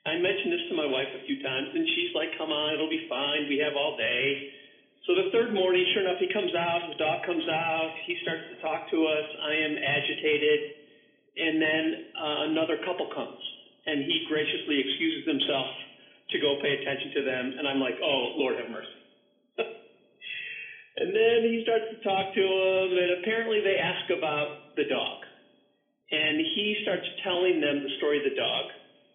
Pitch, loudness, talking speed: 180 Hz, -28 LUFS, 180 wpm